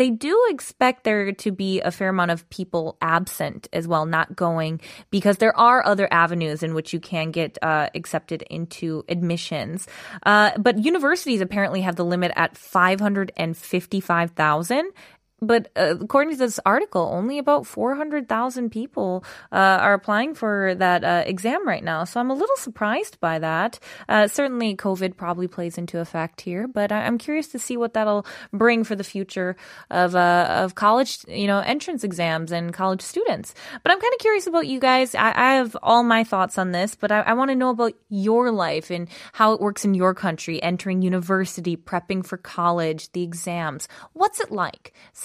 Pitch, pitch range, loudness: 195 Hz, 175-235 Hz, -22 LUFS